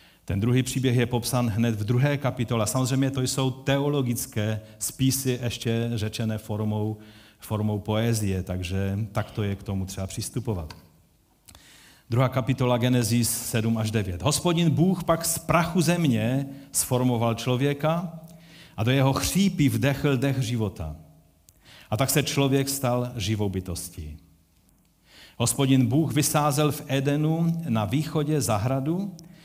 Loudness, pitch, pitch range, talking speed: -25 LUFS, 125 Hz, 110-140 Hz, 130 wpm